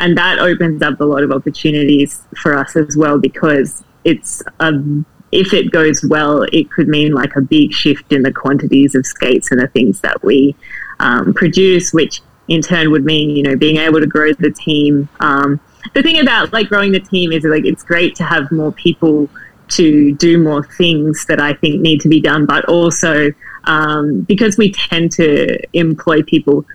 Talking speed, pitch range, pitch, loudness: 195 wpm, 145-170 Hz, 155 Hz, -12 LUFS